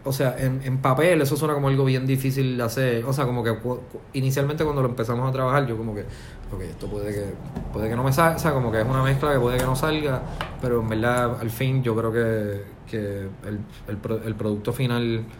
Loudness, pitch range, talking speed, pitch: -24 LUFS, 110-135 Hz, 240 wpm, 125 Hz